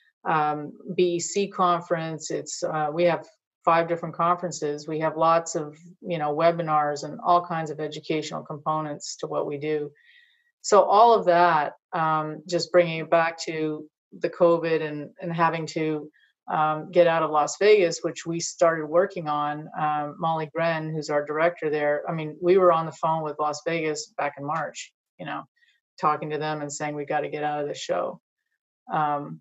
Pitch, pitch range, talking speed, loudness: 160 Hz, 150-175 Hz, 185 wpm, -25 LUFS